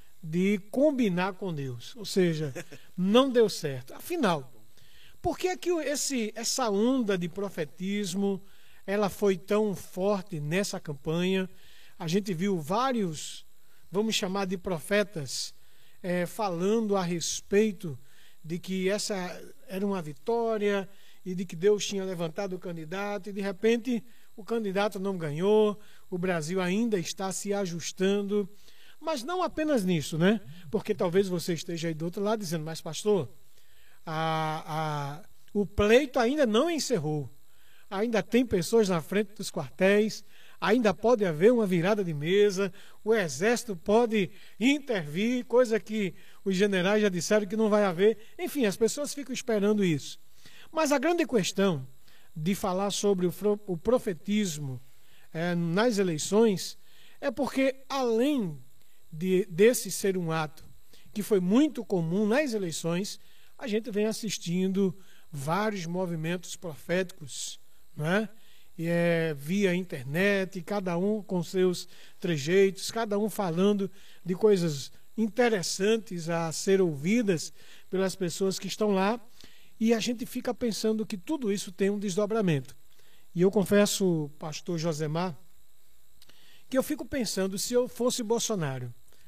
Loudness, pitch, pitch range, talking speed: -28 LUFS, 195 Hz, 175-215 Hz, 135 wpm